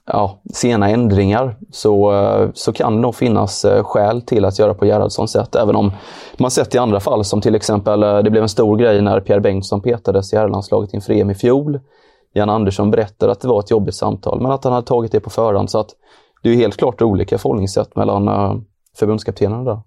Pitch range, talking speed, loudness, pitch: 100-120 Hz, 210 wpm, -15 LUFS, 105 Hz